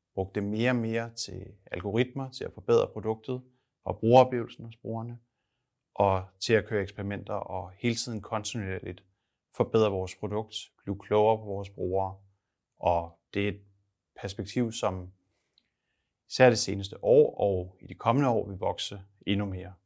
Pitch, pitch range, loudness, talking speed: 105 Hz, 95-115 Hz, -29 LUFS, 155 wpm